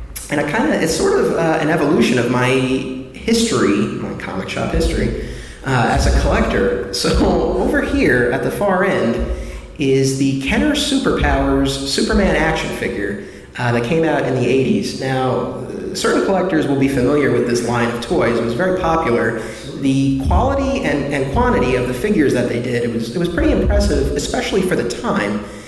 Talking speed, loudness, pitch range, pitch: 180 wpm, -17 LUFS, 115-140 Hz, 130 Hz